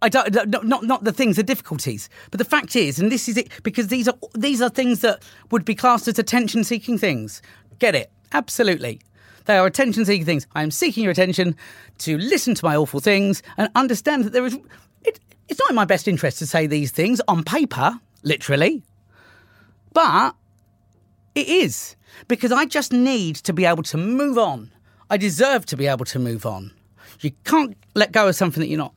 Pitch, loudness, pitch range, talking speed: 205 Hz, -20 LUFS, 150-245 Hz, 205 wpm